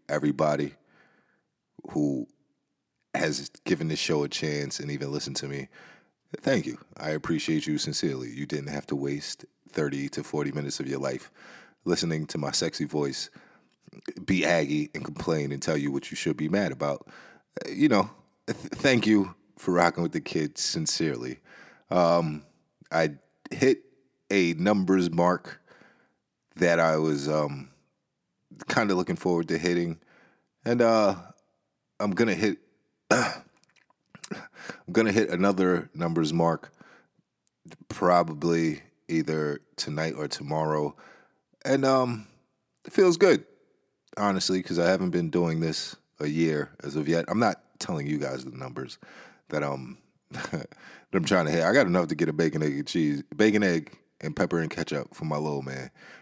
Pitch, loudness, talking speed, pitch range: 80 Hz, -27 LUFS, 155 wpm, 75-90 Hz